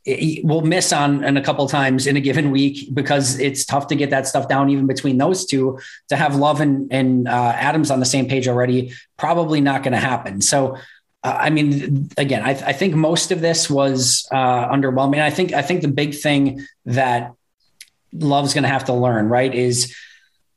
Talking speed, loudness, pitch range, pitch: 215 wpm, -18 LUFS, 130-145 Hz, 140 Hz